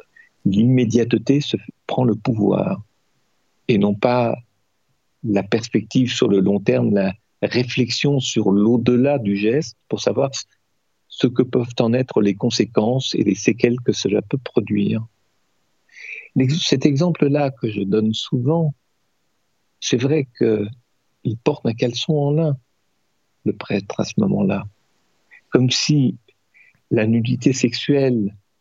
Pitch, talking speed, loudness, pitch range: 120 Hz, 125 wpm, -19 LUFS, 110-135 Hz